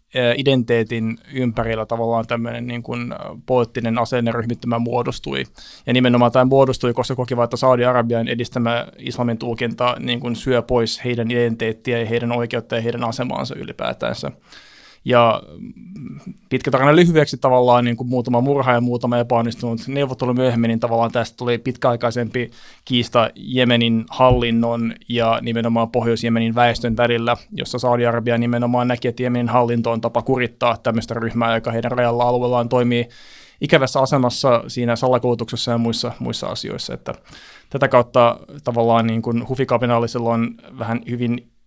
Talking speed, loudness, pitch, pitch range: 135 wpm, -19 LUFS, 120 Hz, 115-125 Hz